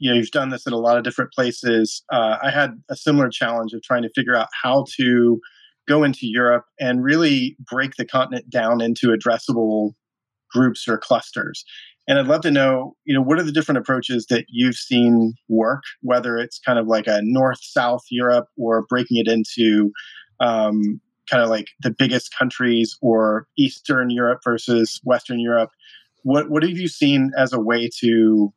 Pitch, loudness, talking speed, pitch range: 120 Hz, -19 LUFS, 185 wpm, 115-130 Hz